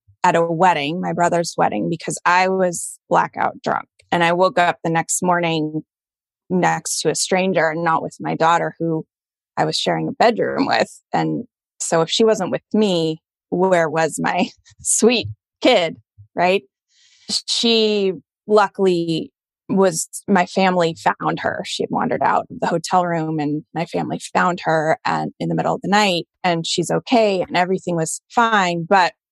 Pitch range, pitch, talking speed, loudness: 160-185 Hz, 175 Hz, 170 wpm, -19 LUFS